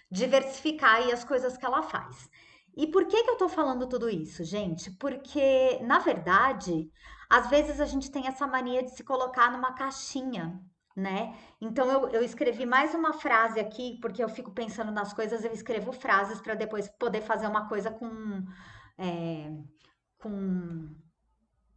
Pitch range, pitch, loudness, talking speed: 205-265 Hz, 235 Hz, -29 LUFS, 165 wpm